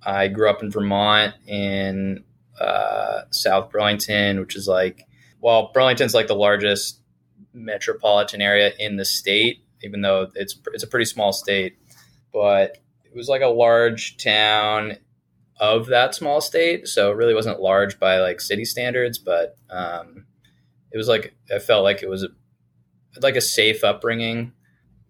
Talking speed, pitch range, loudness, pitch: 155 wpm, 95-115 Hz, -20 LUFS, 105 Hz